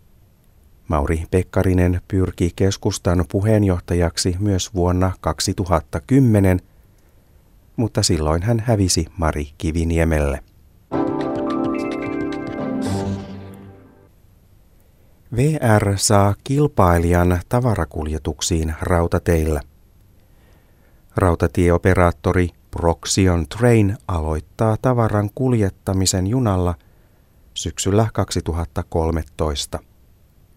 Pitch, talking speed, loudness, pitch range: 90 Hz, 55 wpm, -19 LUFS, 85-100 Hz